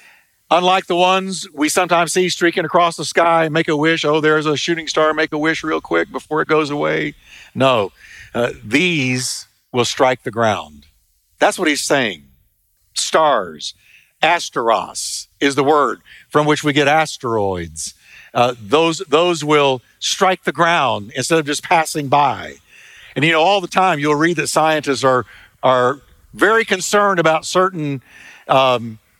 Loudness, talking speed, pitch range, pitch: -16 LUFS, 160 wpm, 130-170 Hz, 155 Hz